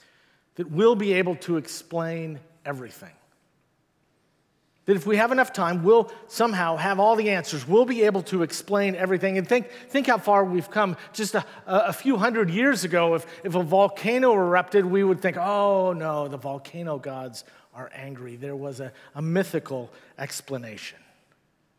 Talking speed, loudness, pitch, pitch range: 165 wpm, -23 LUFS, 185 Hz, 155-210 Hz